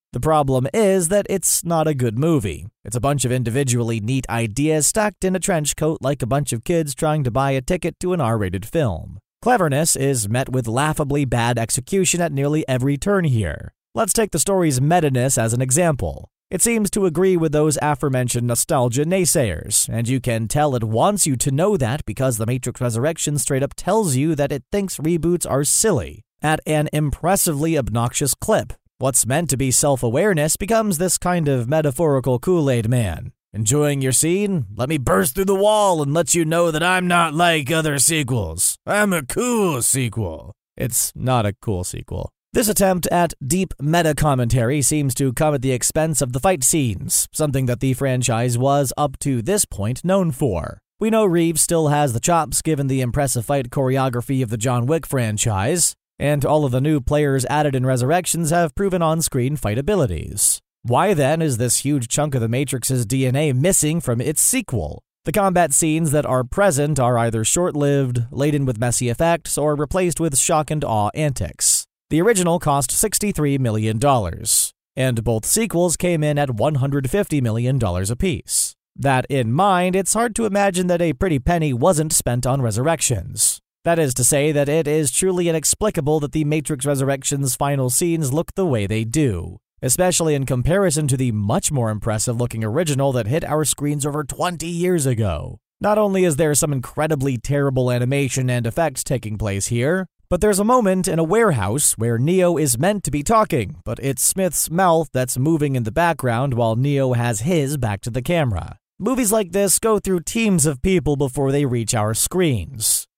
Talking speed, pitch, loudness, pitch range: 185 wpm, 145 Hz, -19 LUFS, 125-170 Hz